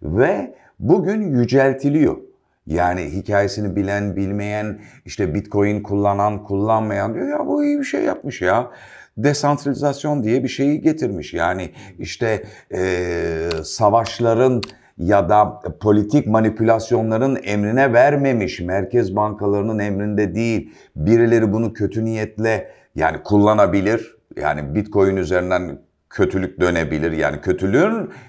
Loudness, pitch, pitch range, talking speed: -19 LUFS, 105 Hz, 100-120 Hz, 110 wpm